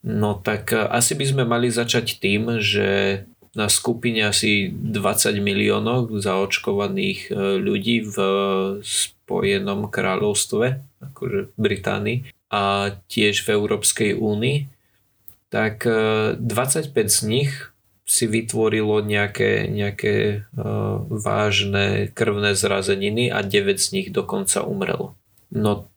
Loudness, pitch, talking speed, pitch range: -21 LUFS, 105 Hz, 105 wpm, 100-120 Hz